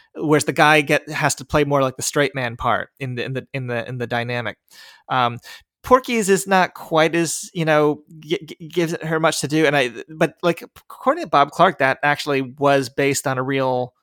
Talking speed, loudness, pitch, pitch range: 225 wpm, -19 LUFS, 145 Hz, 130-160 Hz